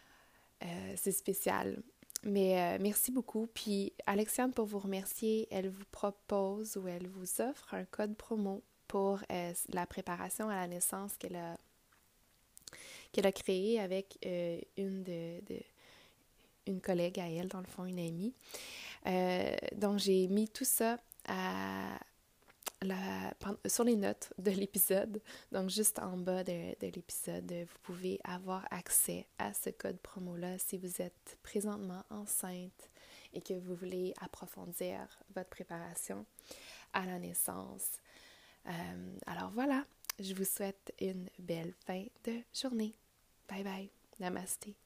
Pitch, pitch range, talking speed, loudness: 190 Hz, 180-210 Hz, 140 wpm, -38 LUFS